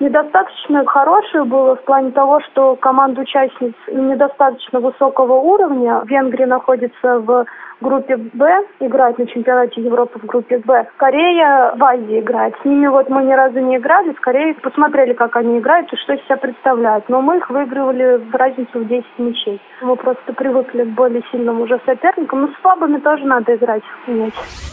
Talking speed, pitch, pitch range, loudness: 175 wpm, 260 Hz, 245-275 Hz, -14 LUFS